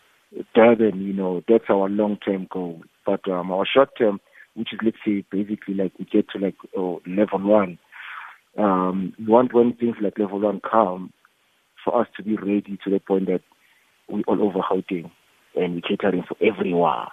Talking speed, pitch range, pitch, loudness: 185 wpm, 95-105 Hz, 100 Hz, -22 LUFS